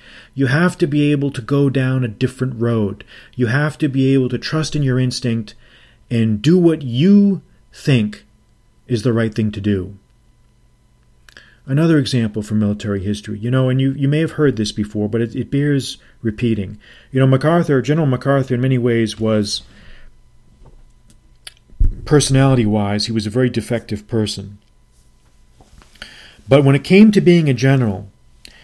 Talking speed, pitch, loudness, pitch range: 160 wpm, 125 Hz, -17 LUFS, 110-140 Hz